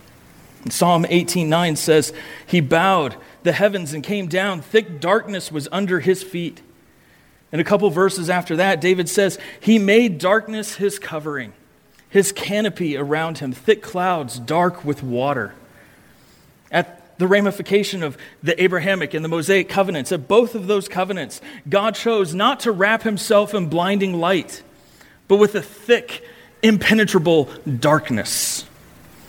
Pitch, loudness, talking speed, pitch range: 185 Hz, -19 LUFS, 140 wpm, 160-200 Hz